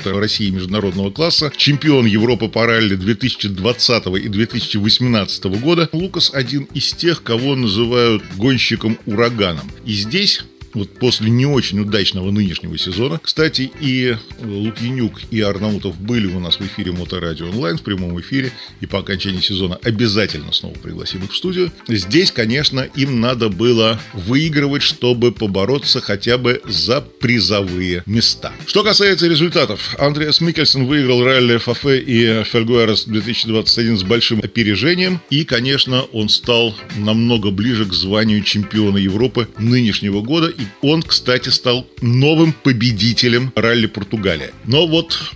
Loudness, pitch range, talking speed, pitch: -15 LUFS, 105-130 Hz, 130 wpm, 115 Hz